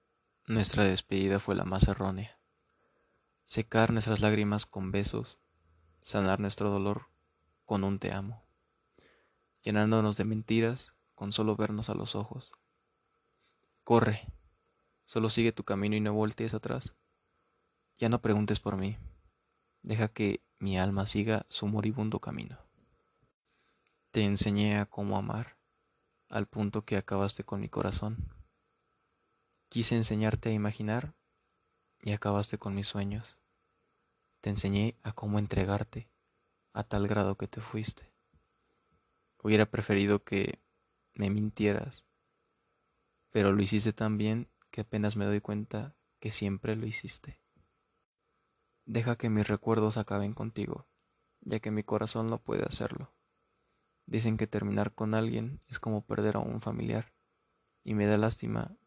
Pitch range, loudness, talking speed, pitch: 100-110 Hz, -32 LUFS, 130 wpm, 105 Hz